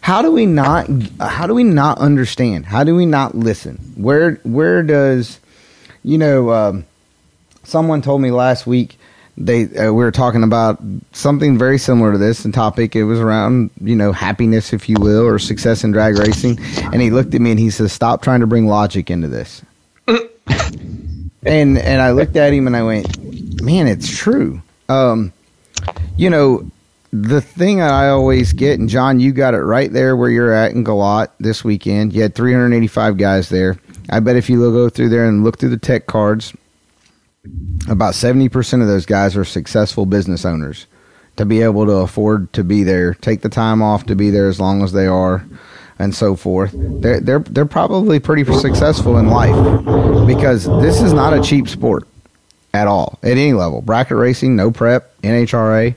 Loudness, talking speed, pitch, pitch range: -14 LUFS, 190 wpm, 110 Hz, 100-125 Hz